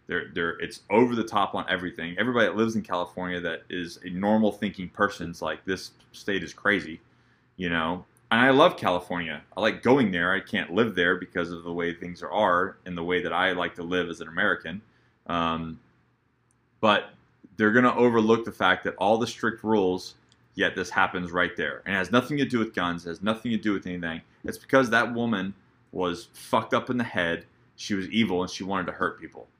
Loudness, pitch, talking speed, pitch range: -26 LUFS, 95 Hz, 220 wpm, 85-115 Hz